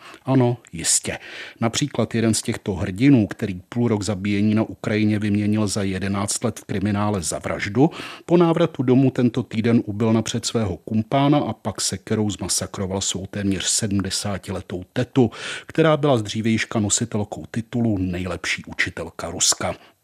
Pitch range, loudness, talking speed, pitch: 100-120 Hz, -21 LUFS, 140 wpm, 110 Hz